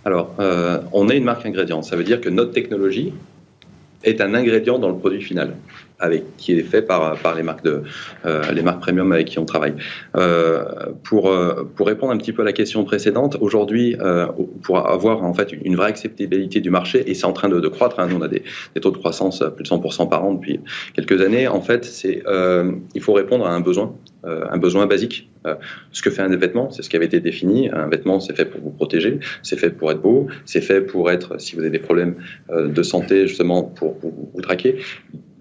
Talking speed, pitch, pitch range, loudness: 235 wpm, 90 Hz, 85-95 Hz, -19 LUFS